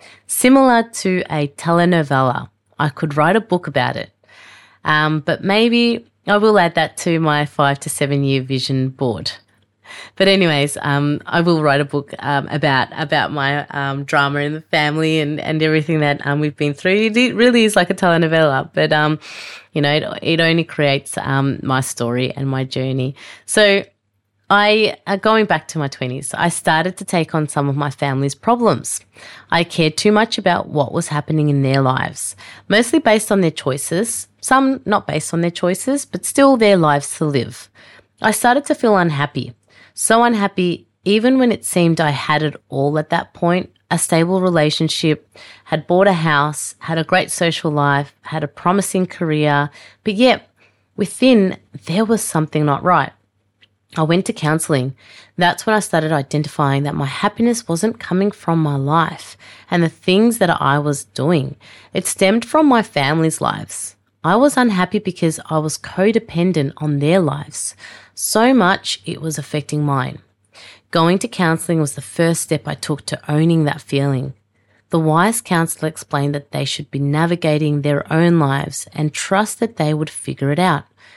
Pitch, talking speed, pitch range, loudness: 155 Hz, 175 wpm, 145-185 Hz, -17 LUFS